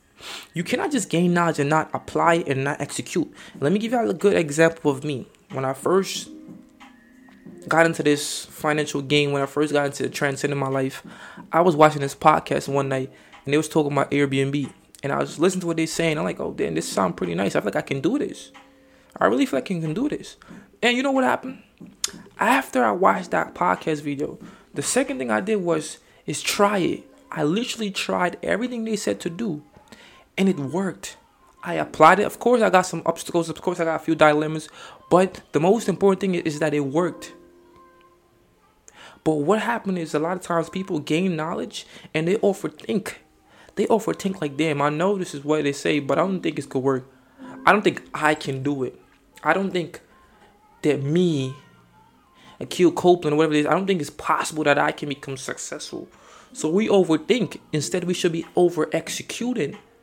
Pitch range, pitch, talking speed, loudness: 145-195 Hz, 165 Hz, 205 wpm, -22 LUFS